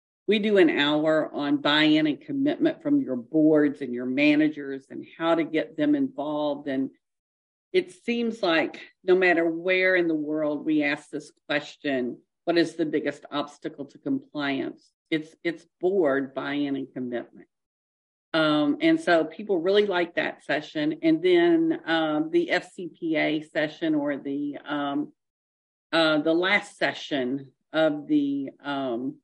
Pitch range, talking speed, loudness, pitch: 145-205 Hz, 145 wpm, -25 LUFS, 160 Hz